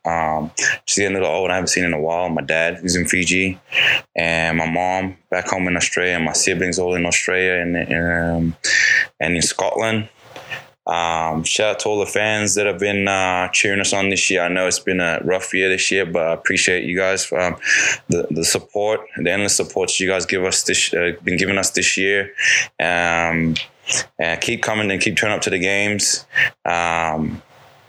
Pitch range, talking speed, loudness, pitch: 85-100 Hz, 205 wpm, -18 LUFS, 90 Hz